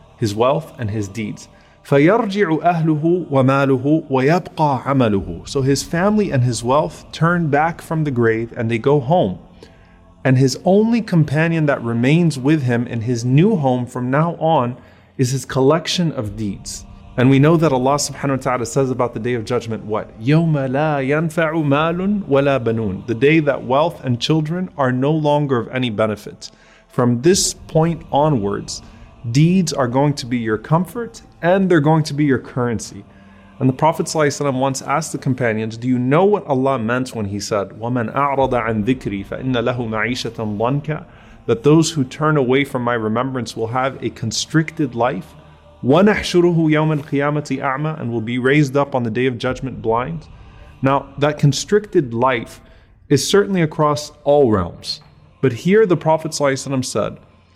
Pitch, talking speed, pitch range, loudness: 135 Hz, 145 wpm, 115-155 Hz, -18 LUFS